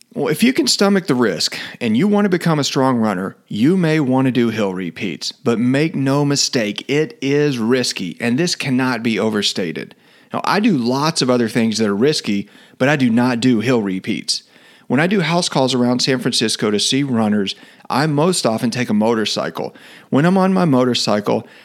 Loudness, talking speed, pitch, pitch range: -17 LUFS, 200 wpm, 130 Hz, 115-160 Hz